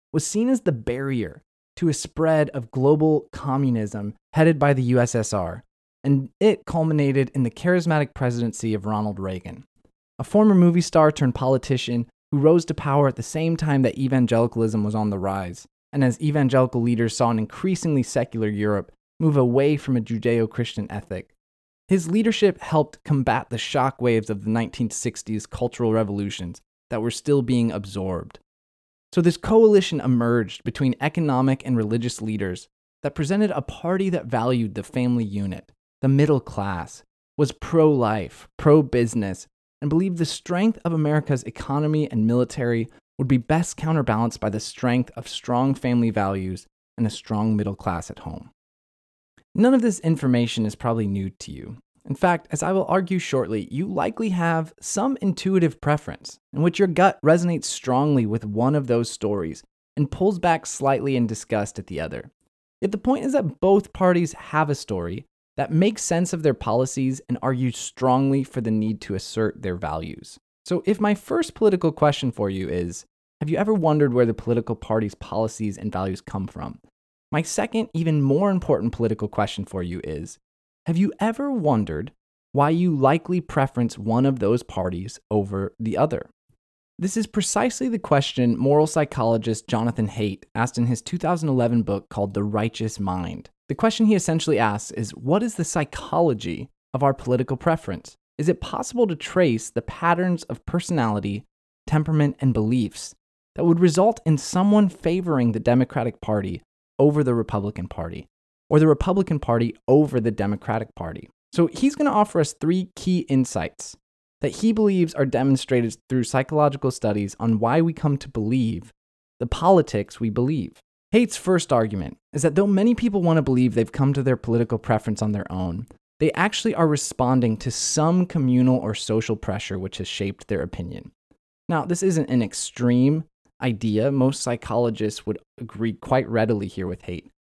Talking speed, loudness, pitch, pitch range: 170 wpm, -22 LUFS, 130 Hz, 110-160 Hz